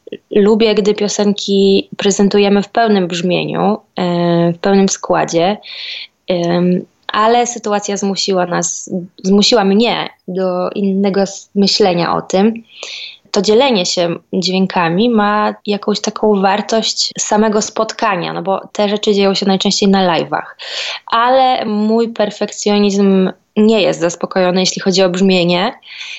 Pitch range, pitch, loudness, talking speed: 185-210 Hz, 200 Hz, -14 LUFS, 115 wpm